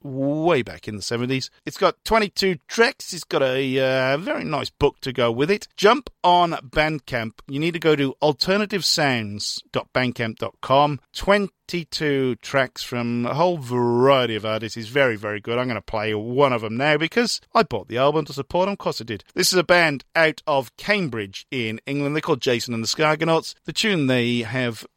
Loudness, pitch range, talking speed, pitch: -21 LUFS, 120-170 Hz, 190 wpm, 140 Hz